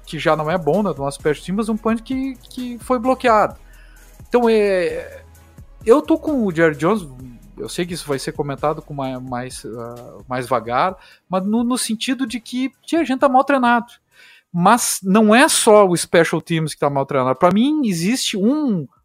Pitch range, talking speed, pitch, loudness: 155-250 Hz, 200 wpm, 205 Hz, -18 LUFS